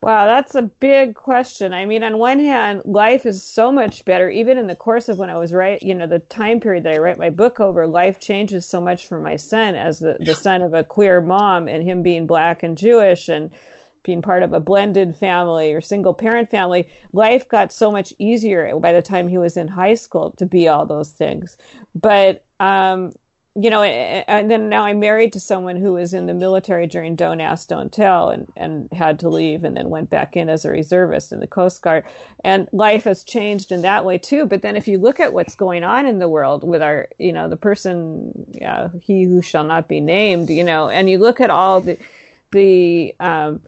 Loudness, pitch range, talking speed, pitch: -13 LUFS, 175-215 Hz, 230 wpm, 190 Hz